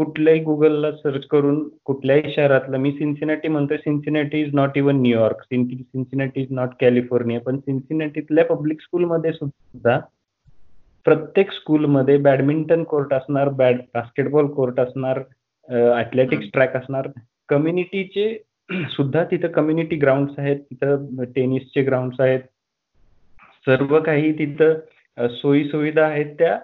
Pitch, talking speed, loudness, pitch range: 140 Hz, 115 wpm, -20 LUFS, 130-155 Hz